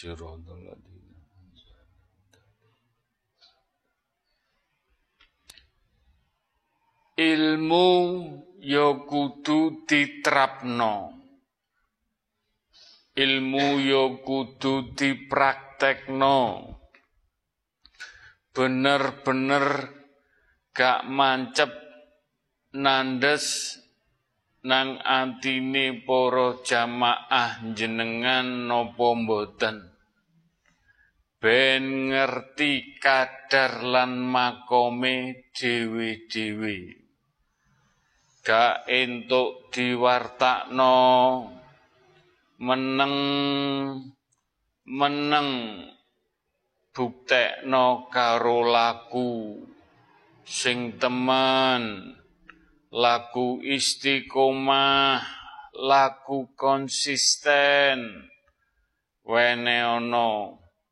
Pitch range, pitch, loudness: 120-140 Hz, 130 Hz, -23 LUFS